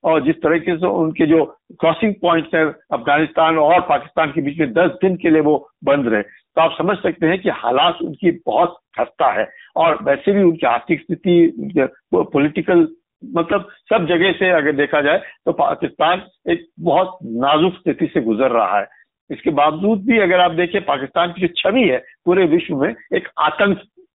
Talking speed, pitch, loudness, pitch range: 180 wpm, 170 Hz, -17 LUFS, 160-190 Hz